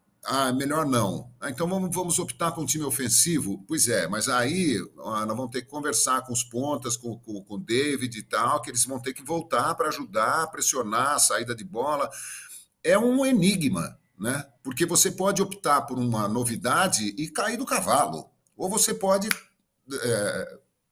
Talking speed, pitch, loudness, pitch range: 180 wpm, 145 Hz, -25 LUFS, 125-185 Hz